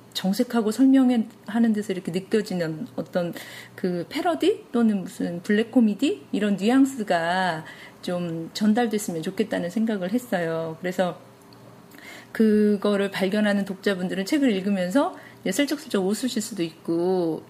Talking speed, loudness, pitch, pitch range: 295 characters per minute, -24 LUFS, 205 Hz, 180-235 Hz